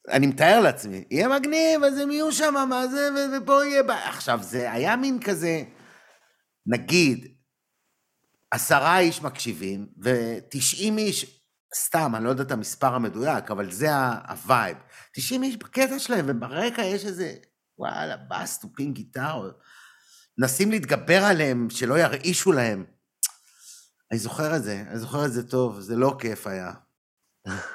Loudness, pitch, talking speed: -24 LUFS, 150 Hz, 145 wpm